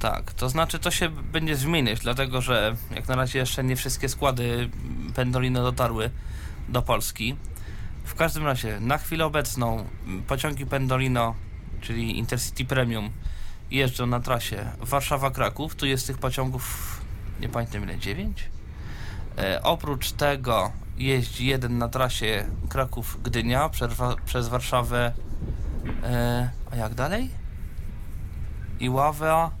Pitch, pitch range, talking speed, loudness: 120 Hz, 105-130 Hz, 120 wpm, -27 LUFS